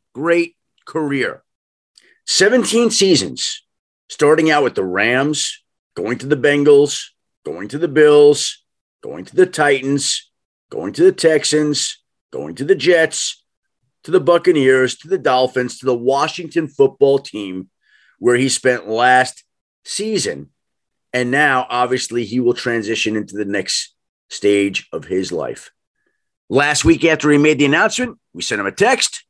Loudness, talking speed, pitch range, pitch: -16 LUFS, 145 wpm, 125-165 Hz, 145 Hz